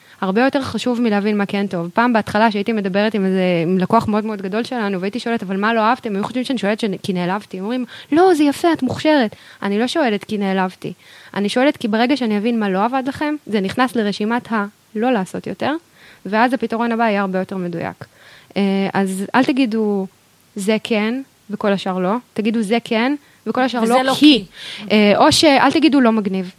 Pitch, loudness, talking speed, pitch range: 220 Hz, -18 LUFS, 190 wpm, 200-250 Hz